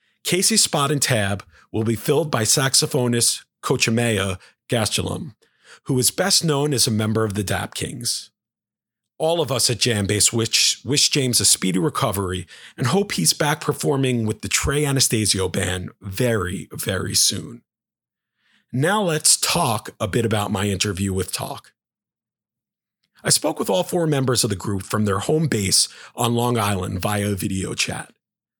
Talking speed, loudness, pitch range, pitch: 155 wpm, -20 LUFS, 100-140 Hz, 115 Hz